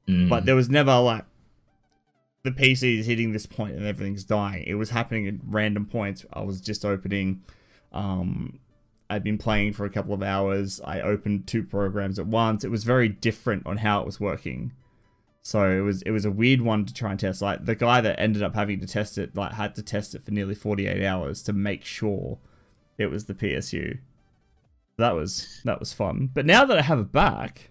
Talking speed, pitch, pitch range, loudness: 210 wpm, 105 Hz, 100-115 Hz, -25 LUFS